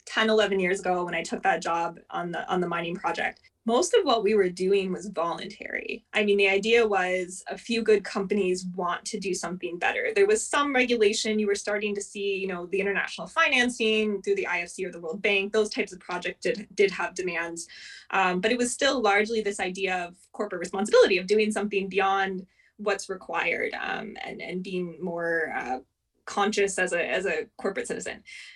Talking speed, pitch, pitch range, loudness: 200 wpm, 195 Hz, 180-215 Hz, -26 LUFS